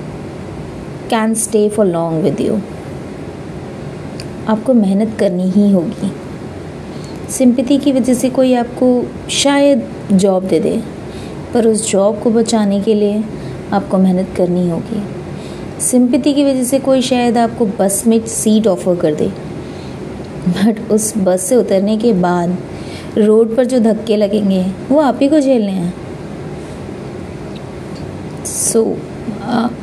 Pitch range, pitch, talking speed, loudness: 195-245 Hz, 215 Hz, 135 wpm, -14 LUFS